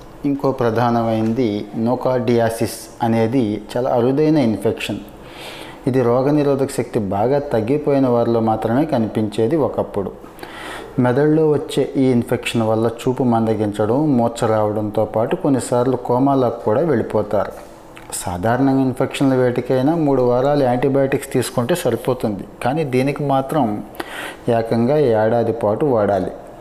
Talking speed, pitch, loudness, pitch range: 100 wpm, 125 Hz, -18 LUFS, 115-135 Hz